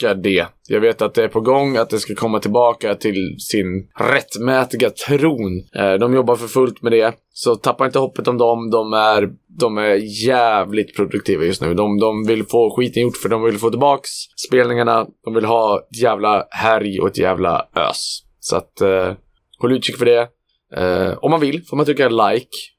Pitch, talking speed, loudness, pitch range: 115 Hz, 195 wpm, -17 LUFS, 110-130 Hz